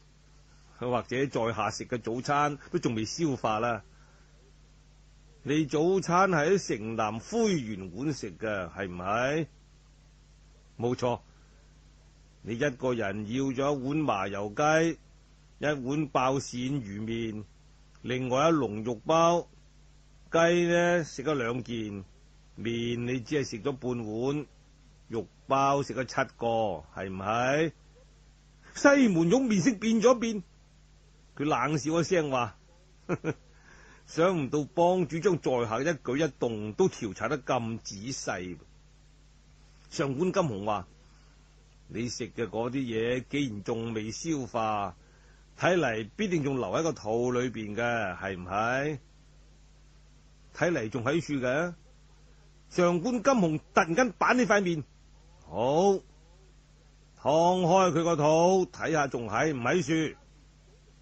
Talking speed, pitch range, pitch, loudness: 170 characters per minute, 115-165 Hz, 135 Hz, -29 LUFS